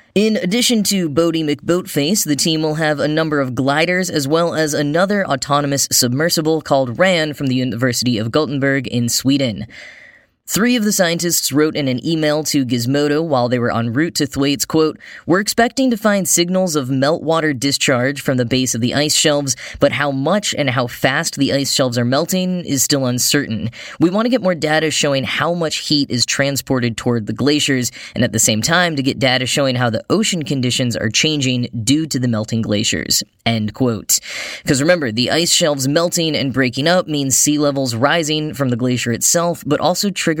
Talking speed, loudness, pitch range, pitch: 195 wpm, -16 LUFS, 130-165 Hz, 145 Hz